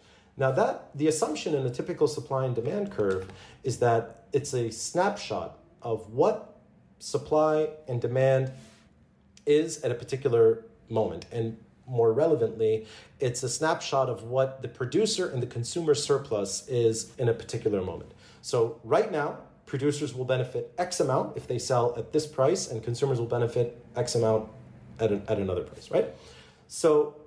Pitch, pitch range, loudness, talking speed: 130 Hz, 115-150 Hz, -28 LUFS, 160 wpm